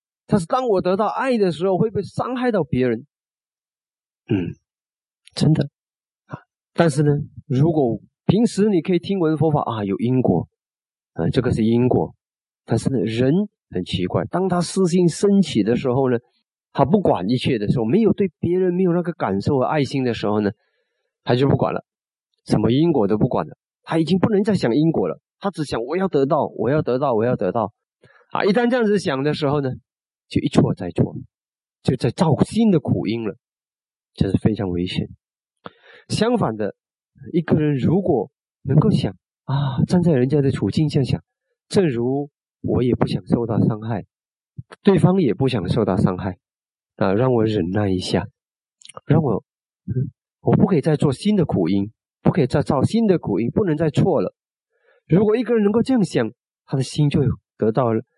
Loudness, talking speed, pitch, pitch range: -20 LUFS, 255 characters per minute, 150 Hz, 125-190 Hz